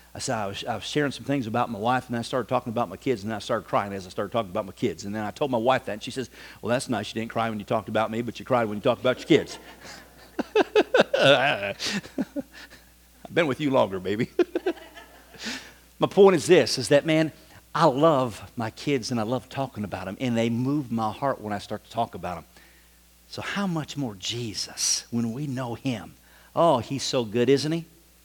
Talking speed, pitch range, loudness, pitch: 230 wpm, 110-145 Hz, -25 LUFS, 125 Hz